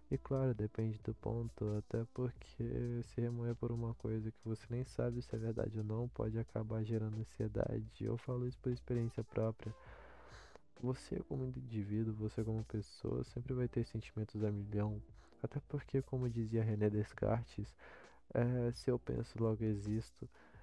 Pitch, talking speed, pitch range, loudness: 115 Hz, 160 wpm, 110-120 Hz, -41 LUFS